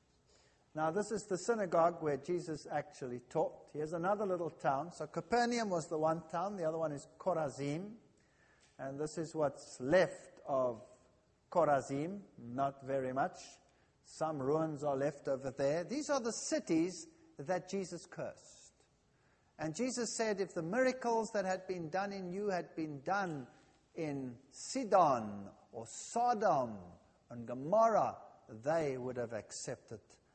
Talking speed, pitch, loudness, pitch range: 140 wpm, 160 Hz, -37 LUFS, 140-200 Hz